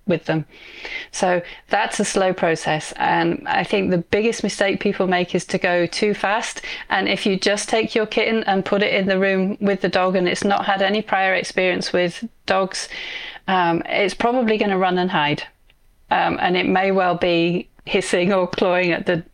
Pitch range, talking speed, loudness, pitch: 180-210 Hz, 200 wpm, -20 LUFS, 190 Hz